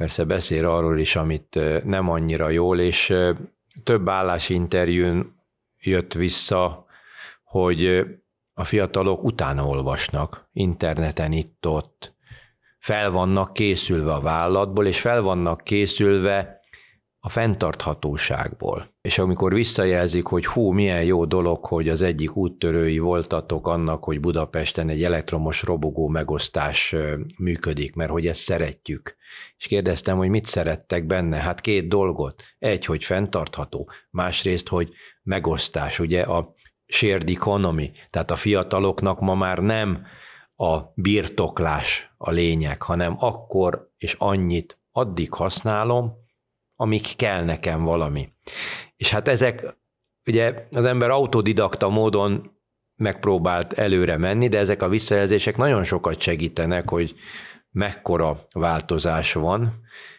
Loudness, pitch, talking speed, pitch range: -22 LUFS, 90 Hz, 115 wpm, 85-100 Hz